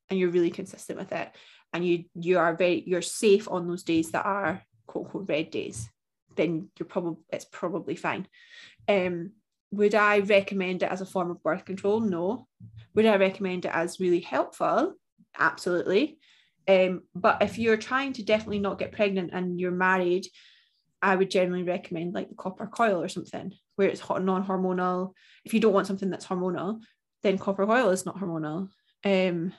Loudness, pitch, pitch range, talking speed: -27 LUFS, 190 Hz, 175-205 Hz, 180 wpm